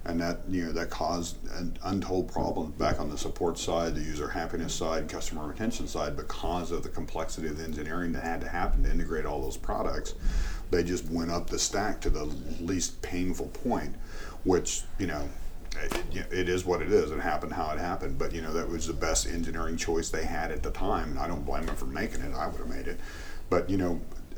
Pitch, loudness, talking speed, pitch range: 85 Hz, -32 LUFS, 230 wpm, 80-85 Hz